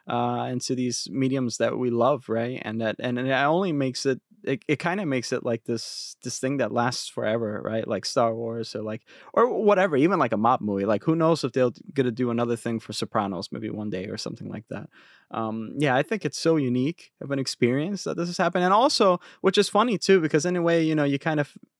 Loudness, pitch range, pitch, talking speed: -25 LUFS, 115-160 Hz, 130 Hz, 240 wpm